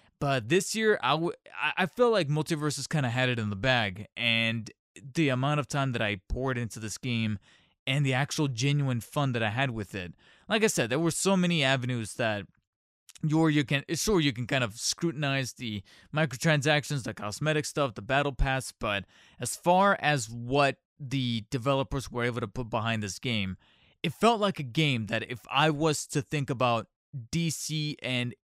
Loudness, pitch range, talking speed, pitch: -28 LUFS, 115-155 Hz, 190 wpm, 135 Hz